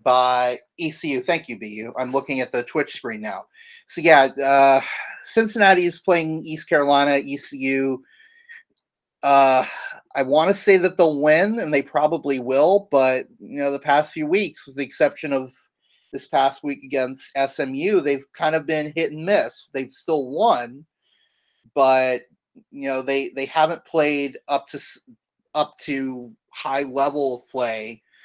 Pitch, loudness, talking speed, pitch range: 140 Hz, -20 LUFS, 155 wpm, 135-160 Hz